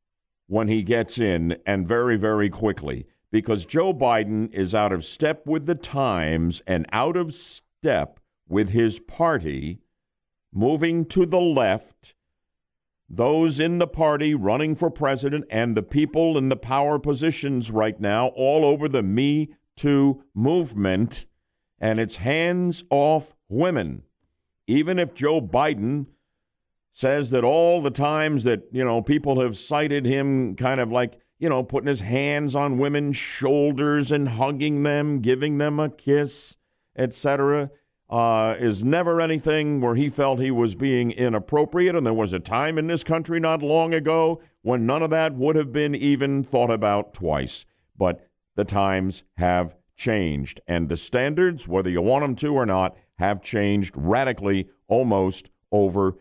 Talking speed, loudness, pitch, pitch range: 155 wpm, -23 LUFS, 135 Hz, 110-150 Hz